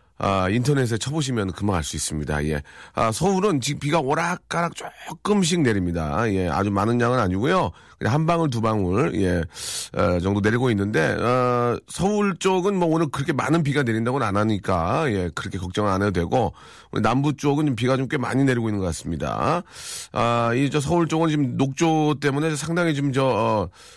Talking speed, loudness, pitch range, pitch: 360 characters per minute, -22 LUFS, 100-155 Hz, 125 Hz